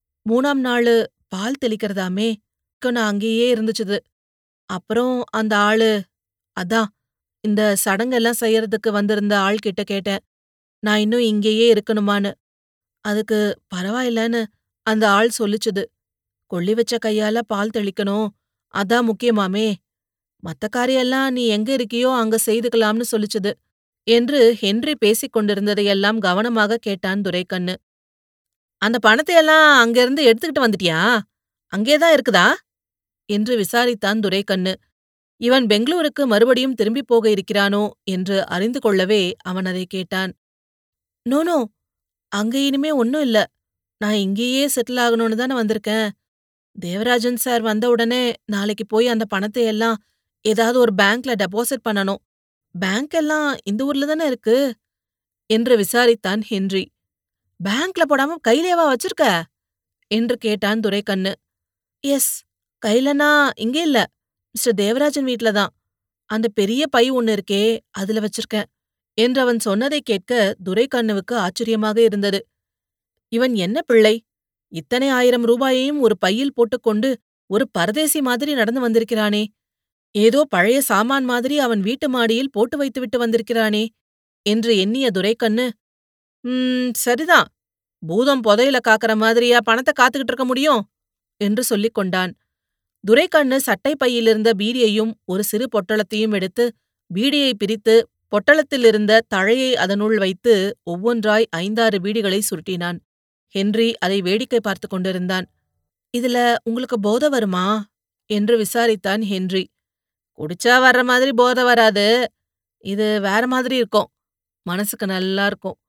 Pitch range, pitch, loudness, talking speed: 200-245 Hz, 220 Hz, -18 LUFS, 110 wpm